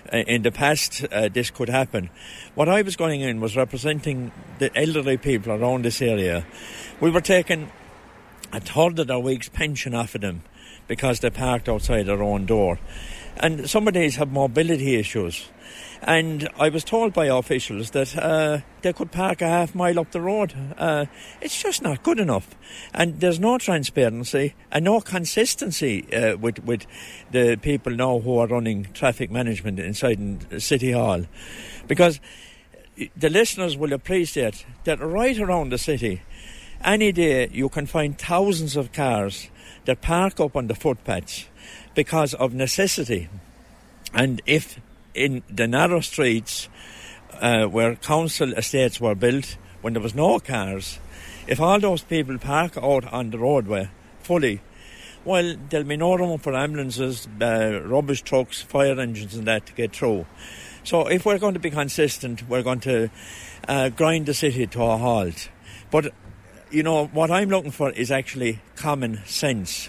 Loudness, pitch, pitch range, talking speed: -23 LUFS, 130 Hz, 115-160 Hz, 160 wpm